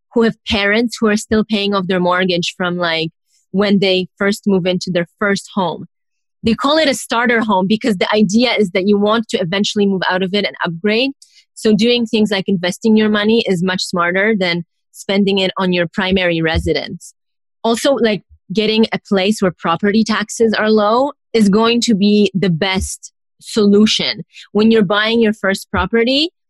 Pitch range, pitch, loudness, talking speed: 190-225 Hz, 205 Hz, -15 LUFS, 185 wpm